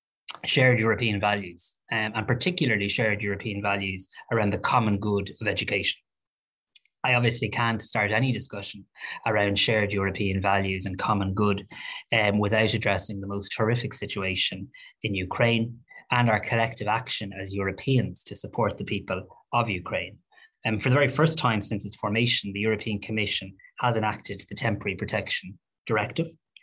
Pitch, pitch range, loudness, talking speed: 105 Hz, 100-115 Hz, -26 LUFS, 155 wpm